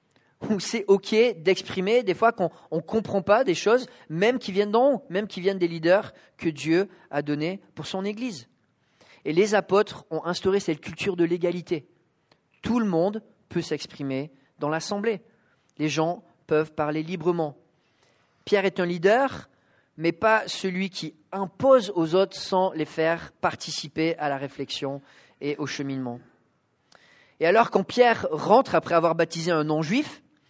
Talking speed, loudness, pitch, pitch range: 160 wpm, -25 LUFS, 175 Hz, 155-205 Hz